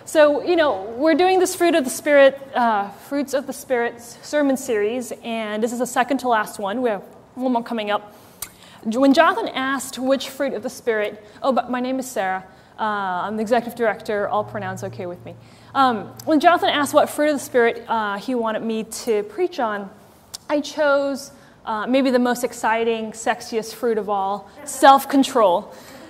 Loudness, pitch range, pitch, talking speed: -20 LUFS, 220-280 Hz, 250 Hz, 190 wpm